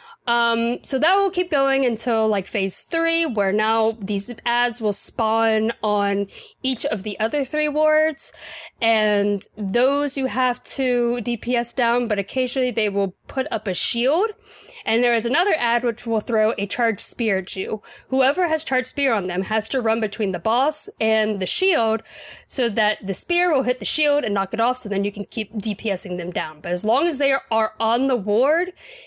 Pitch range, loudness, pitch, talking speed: 215-270 Hz, -20 LUFS, 235 Hz, 195 wpm